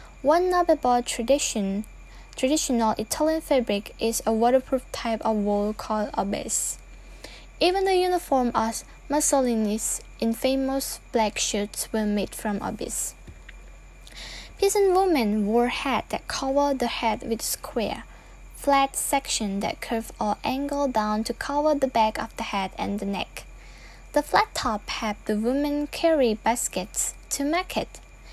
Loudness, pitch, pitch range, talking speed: -25 LUFS, 245 Hz, 220-285 Hz, 135 wpm